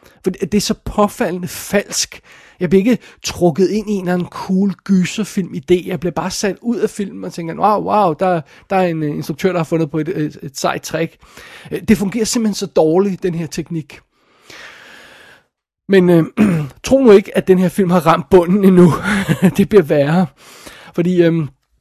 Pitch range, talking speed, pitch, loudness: 170-200 Hz, 185 wpm, 185 Hz, -15 LUFS